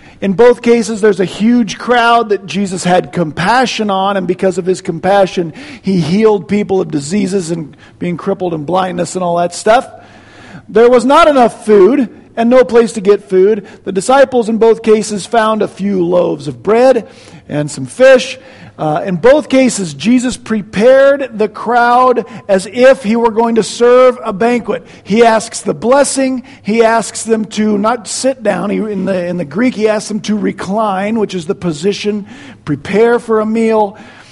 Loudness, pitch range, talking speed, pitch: -11 LUFS, 195-235 Hz, 180 wpm, 215 Hz